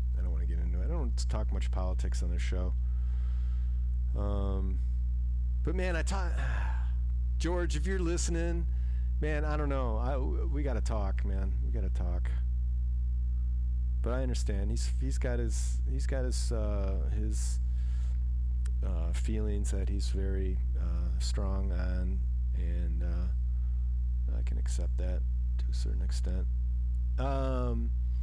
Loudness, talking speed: -33 LUFS, 130 wpm